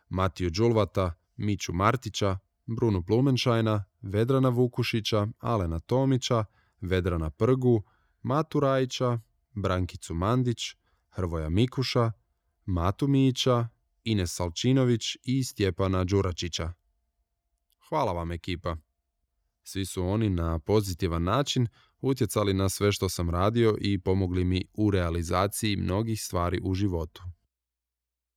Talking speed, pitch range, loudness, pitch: 105 wpm, 90-115 Hz, -28 LUFS, 100 Hz